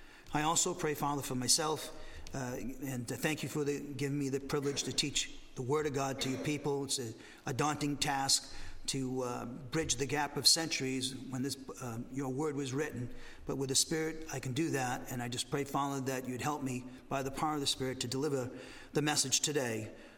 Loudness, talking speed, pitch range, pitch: -34 LUFS, 215 wpm, 130-150 Hz, 140 Hz